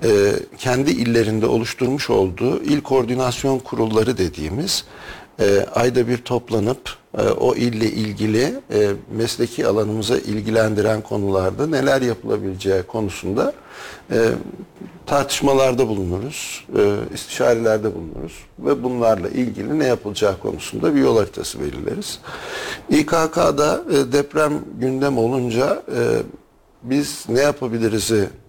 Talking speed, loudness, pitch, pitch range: 90 wpm, -20 LUFS, 120 Hz, 110-135 Hz